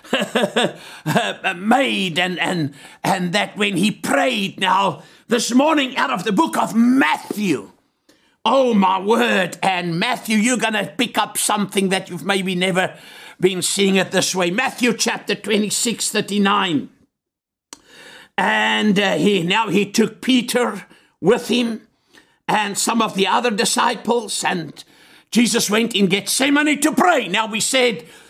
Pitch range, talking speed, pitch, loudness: 190-240 Hz, 140 wpm, 210 Hz, -18 LUFS